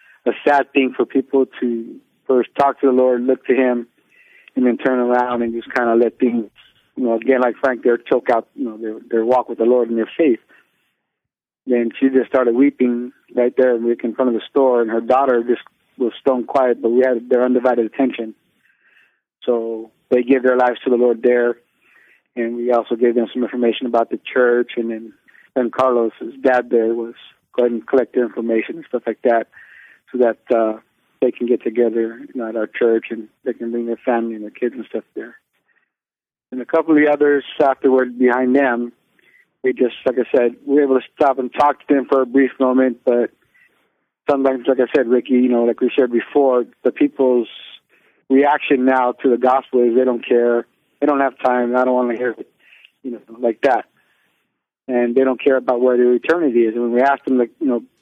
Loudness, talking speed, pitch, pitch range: -17 LUFS, 215 wpm, 125 Hz, 120-130 Hz